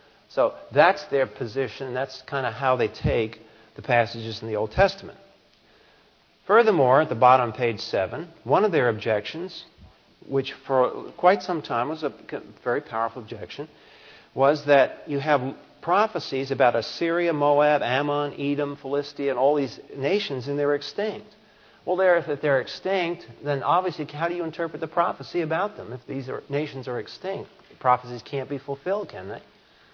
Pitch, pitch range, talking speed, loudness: 140 Hz, 130-165 Hz, 165 wpm, -24 LUFS